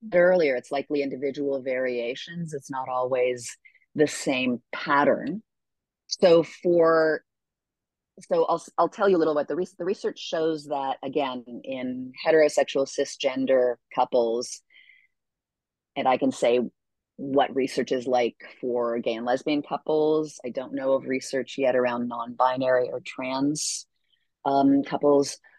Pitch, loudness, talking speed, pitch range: 135 Hz, -25 LUFS, 135 wpm, 125-155 Hz